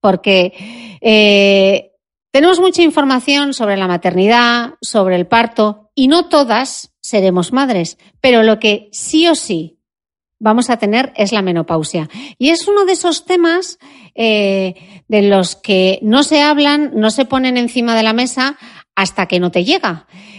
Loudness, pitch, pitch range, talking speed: -13 LUFS, 220 Hz, 195-270 Hz, 155 wpm